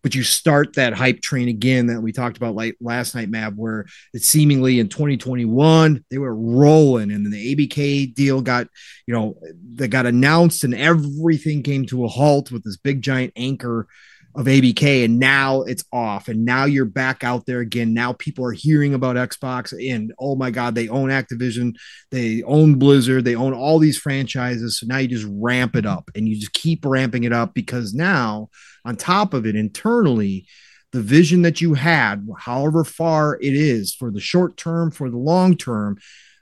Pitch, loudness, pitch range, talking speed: 130 Hz, -18 LUFS, 120-145 Hz, 195 wpm